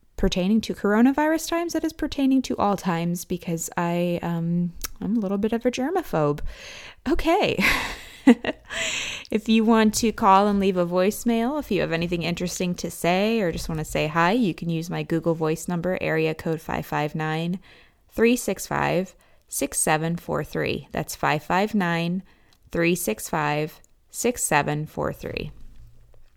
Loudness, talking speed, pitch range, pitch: -24 LUFS, 135 wpm, 165-225 Hz, 180 Hz